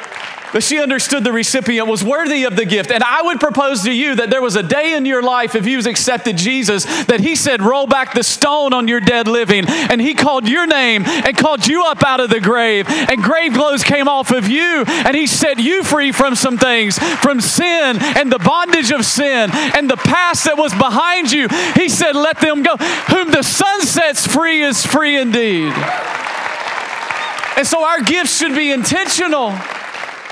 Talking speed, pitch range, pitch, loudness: 200 wpm, 240-305 Hz, 275 Hz, -13 LUFS